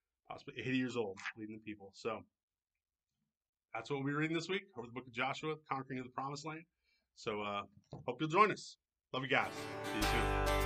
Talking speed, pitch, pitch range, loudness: 210 wpm, 130 Hz, 100-145 Hz, -39 LUFS